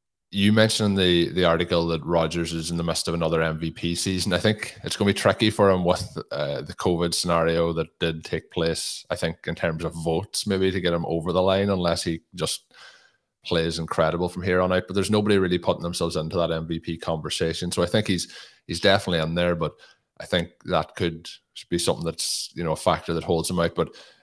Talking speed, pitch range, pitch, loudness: 225 wpm, 80-95 Hz, 85 Hz, -24 LUFS